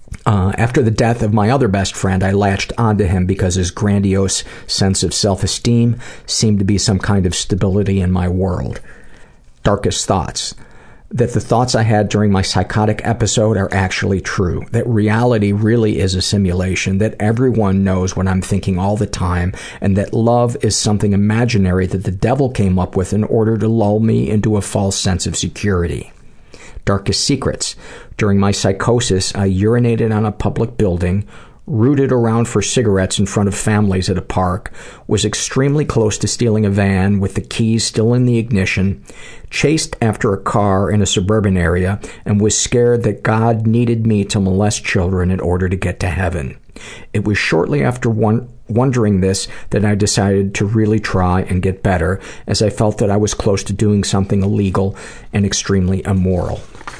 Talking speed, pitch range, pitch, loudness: 180 wpm, 95-110 Hz, 100 Hz, -15 LUFS